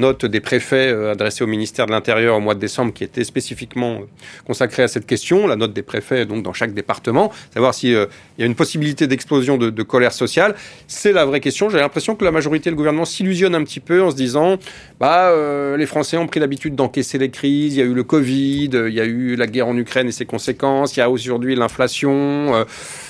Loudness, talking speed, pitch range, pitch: -17 LUFS, 235 wpm, 120-150 Hz, 130 Hz